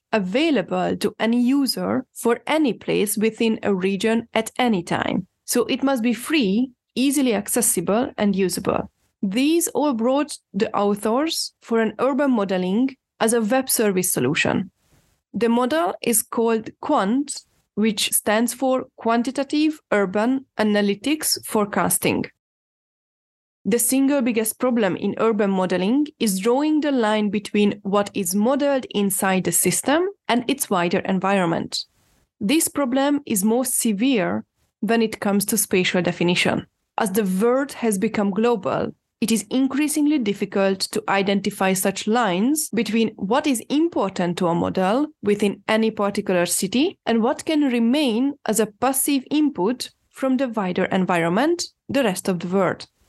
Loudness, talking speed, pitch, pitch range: -21 LUFS, 140 wpm, 225 Hz, 200-265 Hz